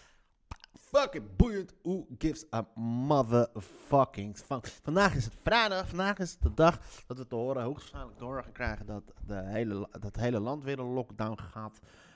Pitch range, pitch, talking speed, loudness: 105-150 Hz, 120 Hz, 165 wpm, -32 LUFS